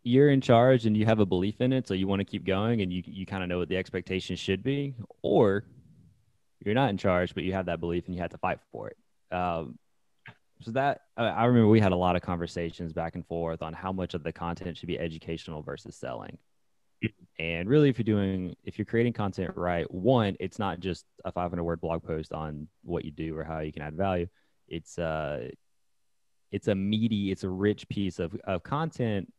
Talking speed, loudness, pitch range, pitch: 225 wpm, -29 LUFS, 85-105 Hz, 95 Hz